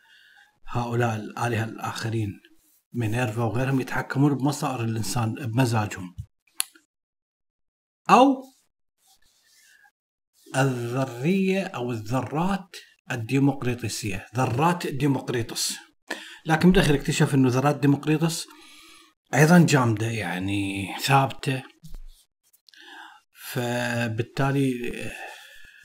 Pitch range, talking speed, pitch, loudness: 115-155 Hz, 65 wpm, 130 Hz, -24 LUFS